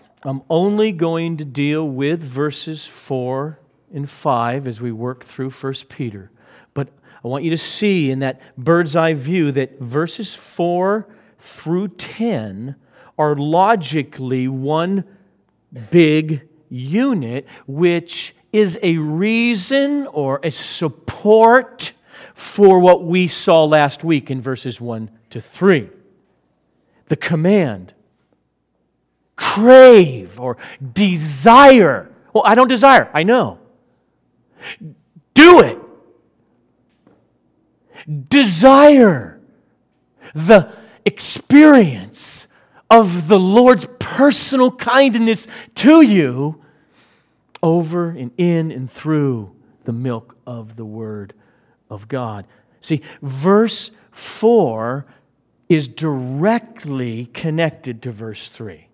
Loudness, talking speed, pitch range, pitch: -14 LUFS, 100 wpm, 130-200 Hz, 155 Hz